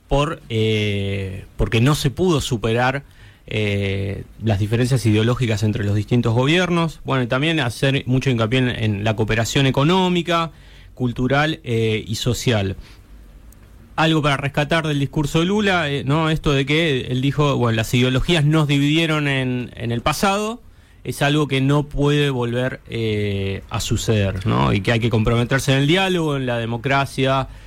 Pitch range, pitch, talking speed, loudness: 110-145 Hz, 130 Hz, 160 wpm, -19 LUFS